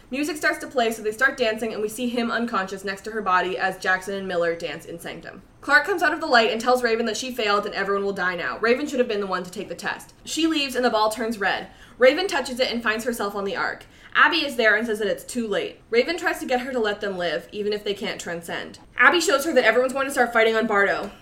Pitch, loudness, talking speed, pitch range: 225 Hz, -22 LUFS, 285 wpm, 200-255 Hz